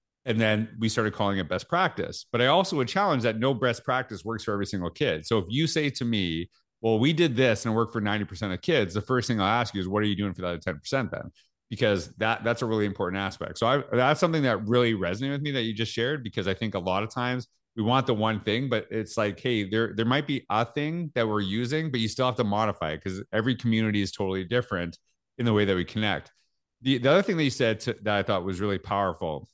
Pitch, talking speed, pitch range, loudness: 110 Hz, 270 wpm, 100-125 Hz, -27 LUFS